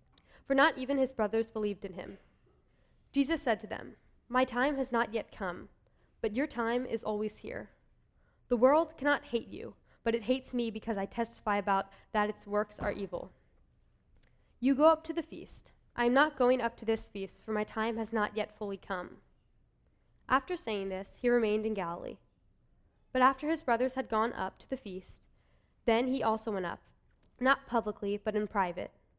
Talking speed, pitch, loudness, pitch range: 185 wpm, 225 Hz, -32 LUFS, 210-260 Hz